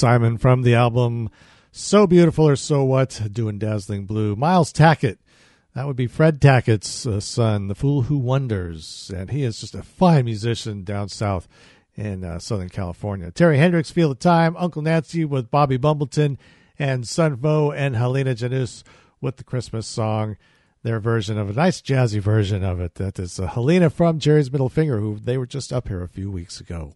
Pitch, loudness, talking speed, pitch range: 125 Hz, -20 LUFS, 185 wpm, 105-145 Hz